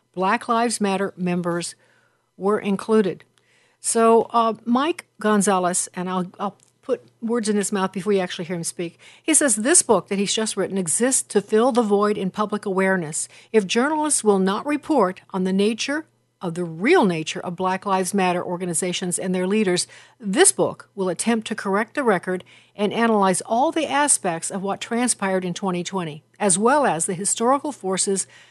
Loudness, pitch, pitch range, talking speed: -21 LUFS, 200 Hz, 185-230 Hz, 175 wpm